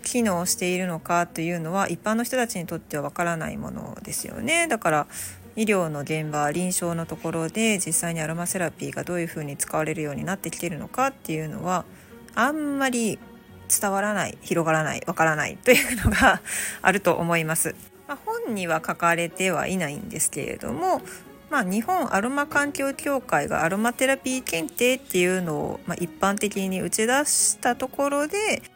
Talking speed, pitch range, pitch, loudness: 380 characters per minute, 165-240 Hz, 185 Hz, -24 LUFS